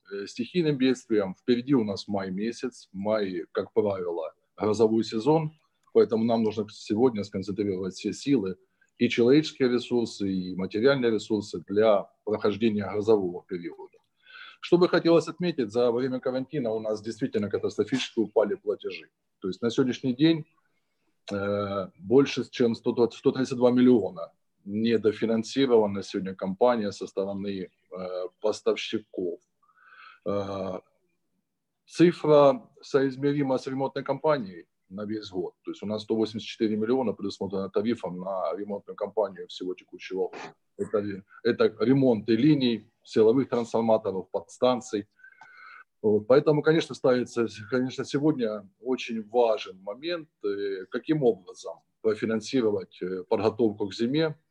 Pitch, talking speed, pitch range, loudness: 120 Hz, 110 wpm, 105-155 Hz, -27 LUFS